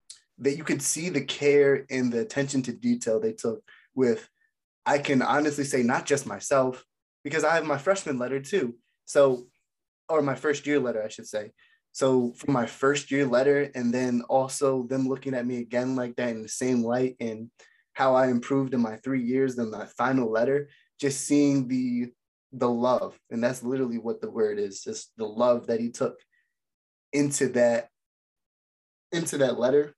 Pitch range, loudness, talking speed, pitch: 120-140 Hz, -26 LUFS, 185 wpm, 130 Hz